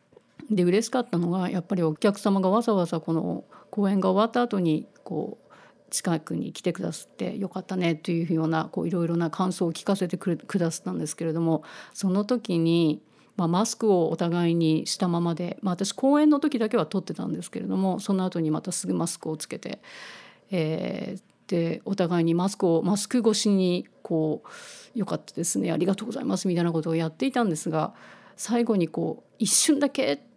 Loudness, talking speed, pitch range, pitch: -26 LUFS, 390 characters per minute, 165-205 Hz, 185 Hz